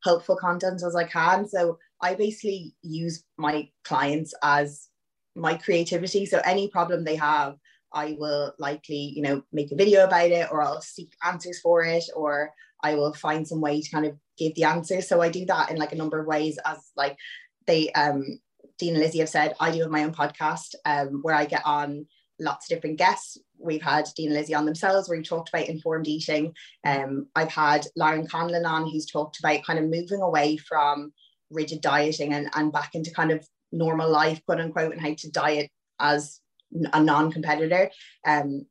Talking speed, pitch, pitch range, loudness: 200 wpm, 155 Hz, 150-170 Hz, -25 LUFS